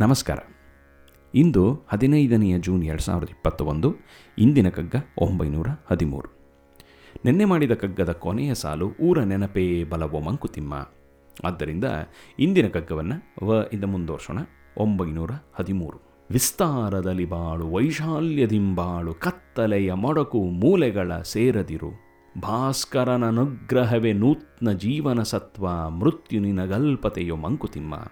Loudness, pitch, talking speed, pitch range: -24 LUFS, 95 Hz, 85 wpm, 80-120 Hz